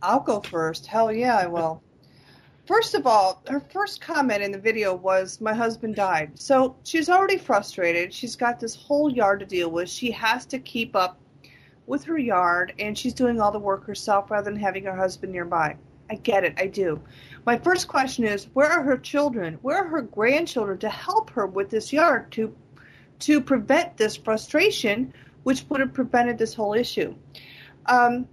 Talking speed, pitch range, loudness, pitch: 190 wpm, 195-270 Hz, -24 LUFS, 225 Hz